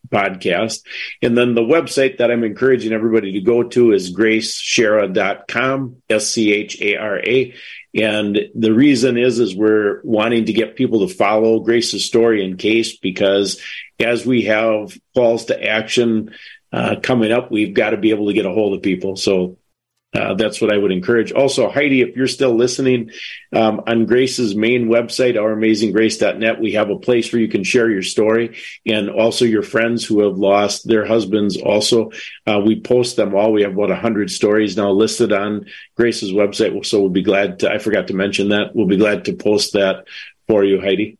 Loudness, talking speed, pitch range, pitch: -16 LUFS, 190 wpm, 105-120 Hz, 110 Hz